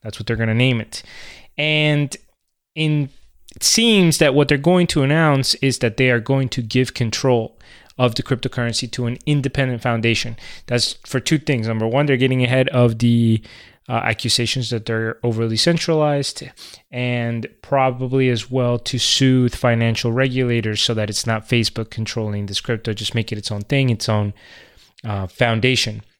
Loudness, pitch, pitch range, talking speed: -18 LUFS, 120 Hz, 115-135 Hz, 170 wpm